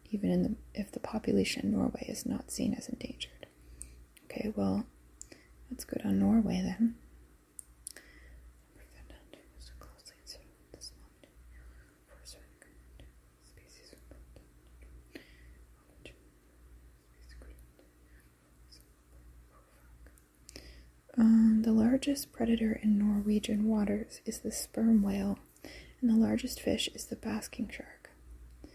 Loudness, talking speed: -31 LUFS, 80 wpm